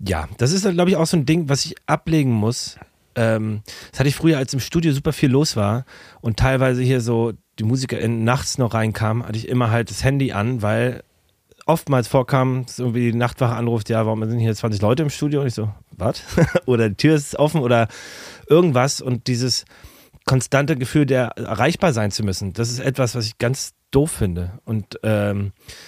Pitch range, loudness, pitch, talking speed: 110-140 Hz, -20 LUFS, 125 Hz, 200 wpm